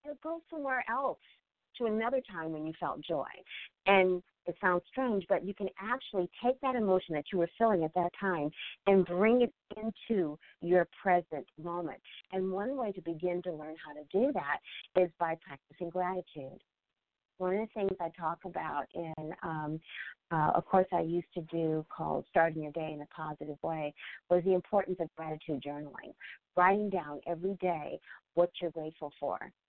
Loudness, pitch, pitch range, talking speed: -34 LUFS, 175 Hz, 160-195 Hz, 180 wpm